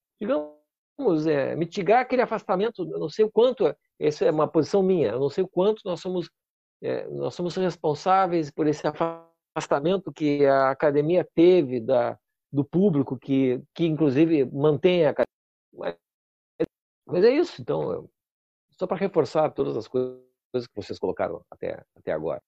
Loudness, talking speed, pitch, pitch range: -24 LUFS, 155 wpm, 165 Hz, 145-190 Hz